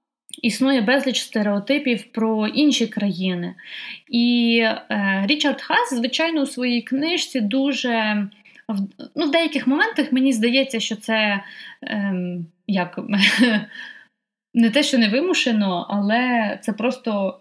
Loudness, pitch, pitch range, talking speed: -20 LUFS, 235 Hz, 210-270 Hz, 115 wpm